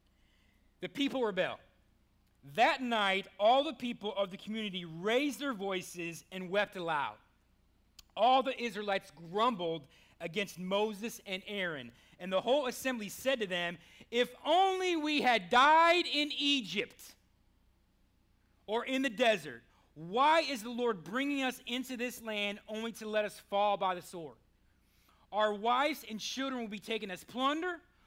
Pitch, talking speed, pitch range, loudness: 210 Hz, 150 wpm, 170-250 Hz, -33 LUFS